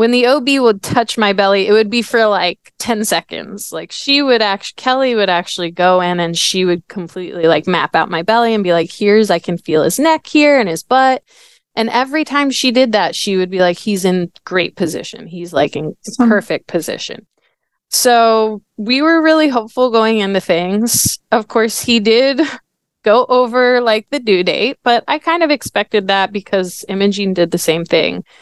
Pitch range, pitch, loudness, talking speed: 185-250 Hz, 215 Hz, -14 LUFS, 200 wpm